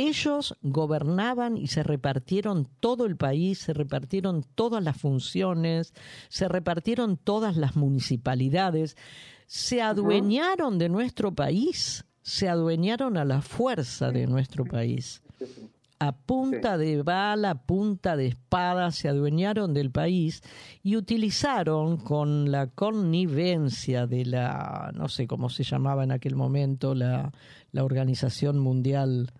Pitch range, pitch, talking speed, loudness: 135-195 Hz, 155 Hz, 125 wpm, -27 LUFS